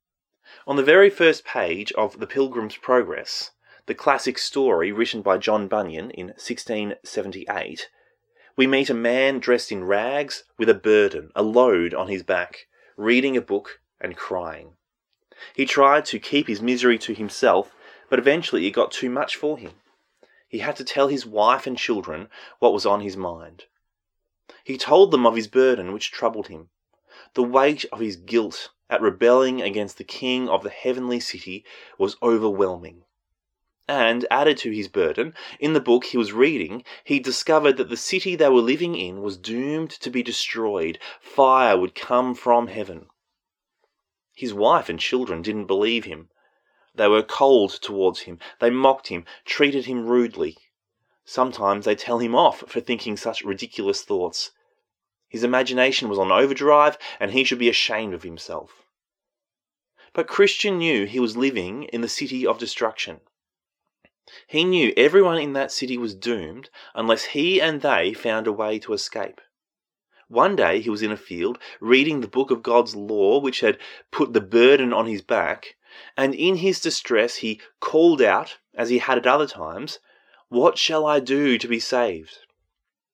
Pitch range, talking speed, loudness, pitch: 110-140 Hz, 170 wpm, -21 LUFS, 125 Hz